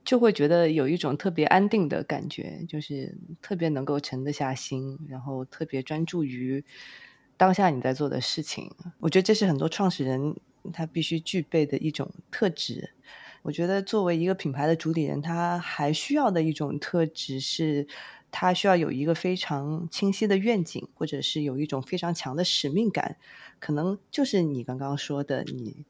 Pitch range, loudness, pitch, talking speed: 145-180 Hz, -27 LUFS, 160 Hz, 275 characters per minute